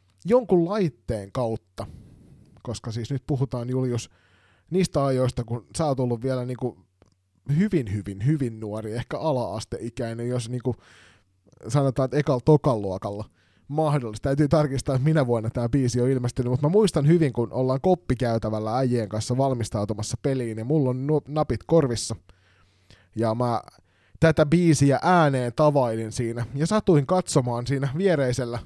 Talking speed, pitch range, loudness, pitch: 140 wpm, 110-145 Hz, -24 LUFS, 125 Hz